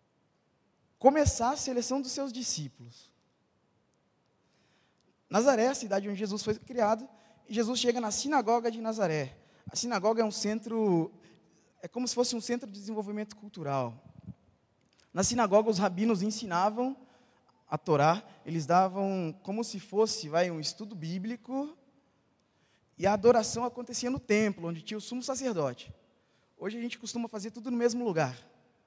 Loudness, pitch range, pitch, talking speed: -30 LUFS, 185-240 Hz, 215 Hz, 150 wpm